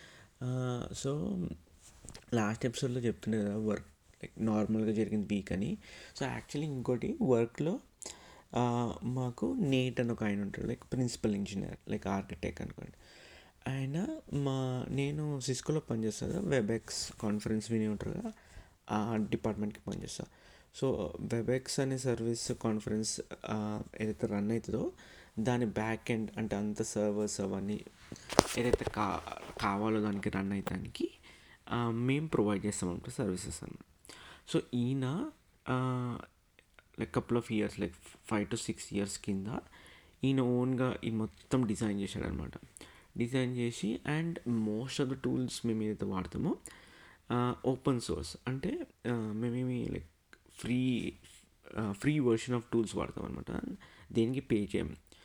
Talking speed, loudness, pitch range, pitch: 120 wpm, -35 LUFS, 105-125 Hz, 115 Hz